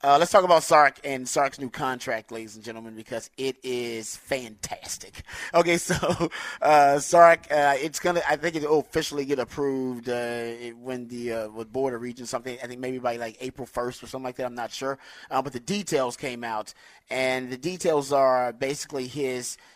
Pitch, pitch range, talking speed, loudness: 130 Hz, 120-145 Hz, 190 wpm, -25 LUFS